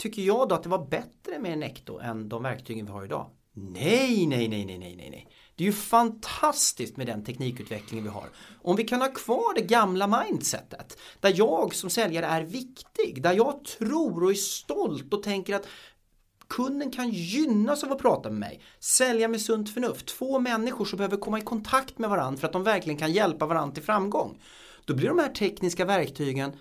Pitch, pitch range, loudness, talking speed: 200 Hz, 150-235 Hz, -27 LUFS, 200 wpm